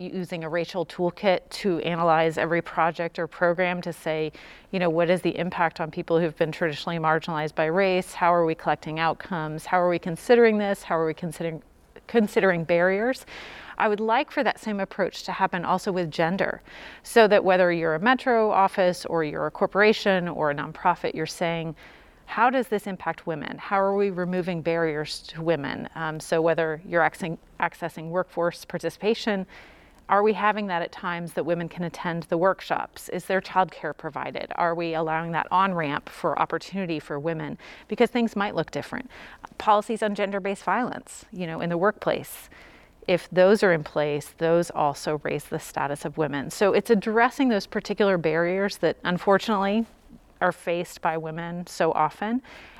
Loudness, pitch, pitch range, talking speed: -25 LUFS, 175 Hz, 165-195 Hz, 175 wpm